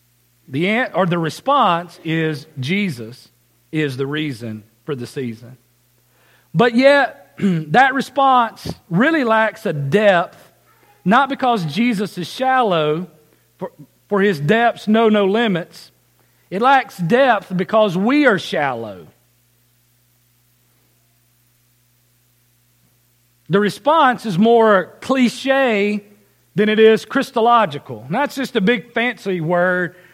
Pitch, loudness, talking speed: 180 Hz, -17 LUFS, 110 wpm